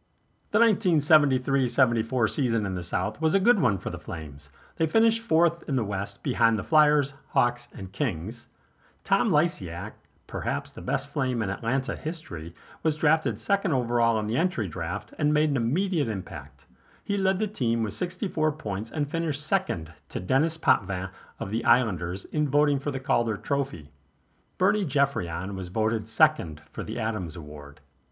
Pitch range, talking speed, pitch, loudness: 100-155 Hz, 165 wpm, 120 Hz, -26 LUFS